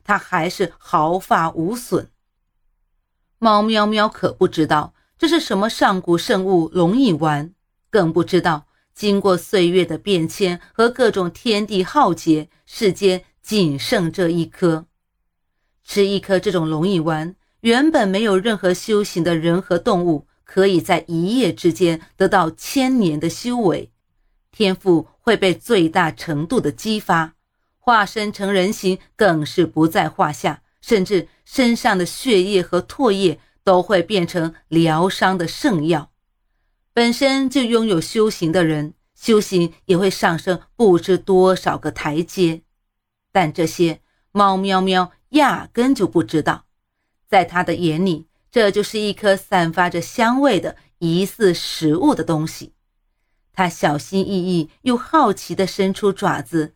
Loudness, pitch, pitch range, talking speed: -18 LUFS, 180 Hz, 165-200 Hz, 205 characters per minute